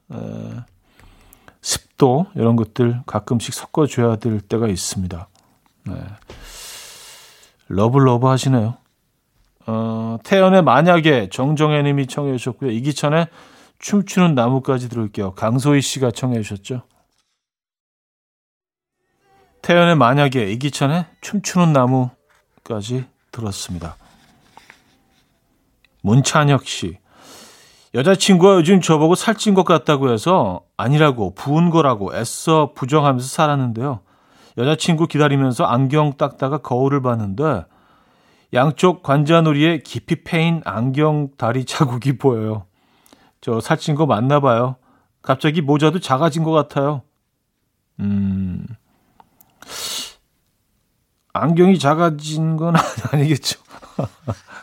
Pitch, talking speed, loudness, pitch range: 135 Hz, 235 characters per minute, -17 LUFS, 115-155 Hz